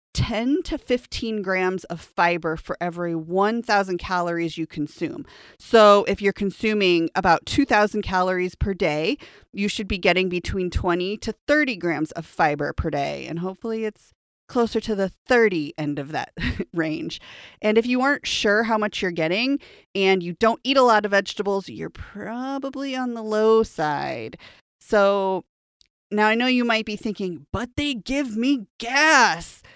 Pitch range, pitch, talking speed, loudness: 180-230 Hz, 205 Hz, 165 wpm, -22 LUFS